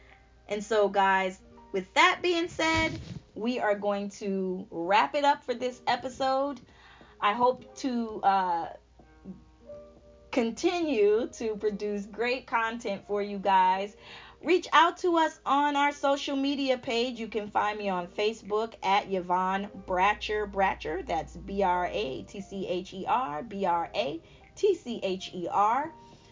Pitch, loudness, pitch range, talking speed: 215 Hz, -28 LUFS, 195-275 Hz, 115 wpm